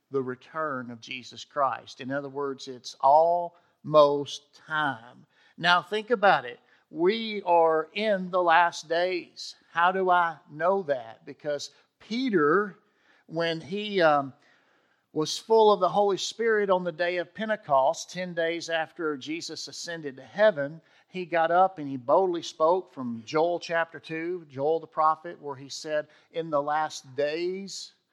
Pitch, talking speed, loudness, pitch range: 165 Hz, 150 wpm, -26 LUFS, 145-180 Hz